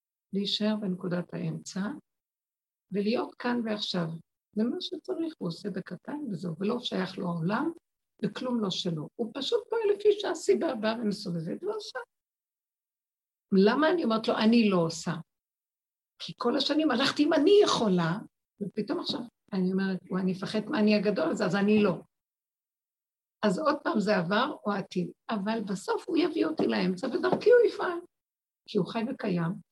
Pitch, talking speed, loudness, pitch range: 215 Hz, 155 wpm, -29 LUFS, 190-295 Hz